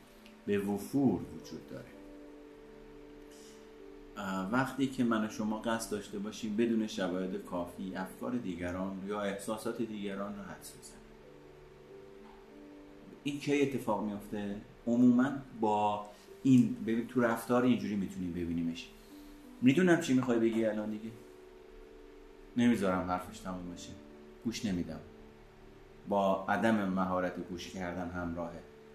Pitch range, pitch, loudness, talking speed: 90-115 Hz, 100 Hz, -33 LUFS, 110 wpm